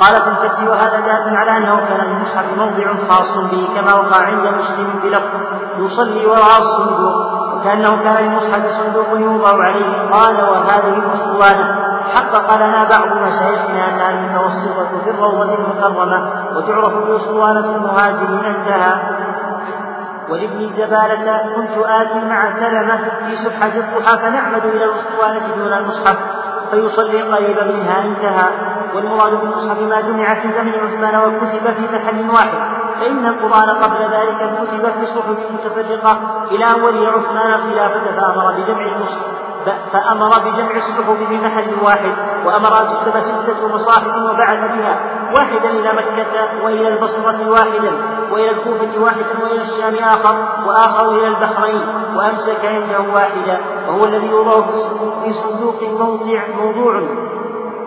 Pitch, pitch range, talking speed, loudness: 220 Hz, 205-220 Hz, 130 wpm, -14 LUFS